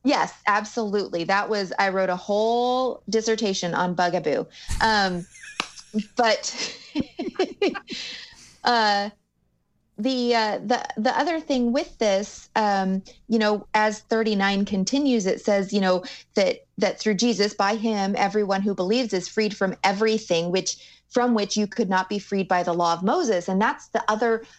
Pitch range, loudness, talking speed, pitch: 195-235 Hz, -24 LUFS, 155 wpm, 215 Hz